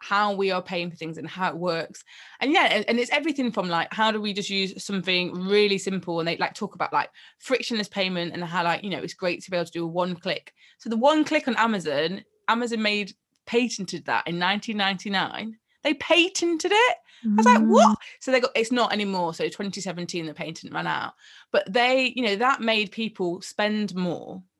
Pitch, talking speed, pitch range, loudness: 205 Hz, 215 wpm, 180-225 Hz, -24 LUFS